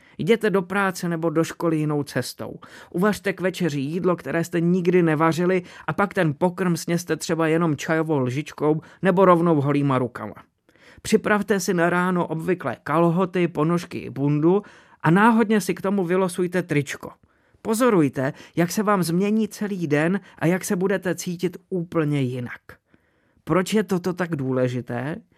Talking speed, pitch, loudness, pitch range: 150 wpm, 175 Hz, -22 LUFS, 155-190 Hz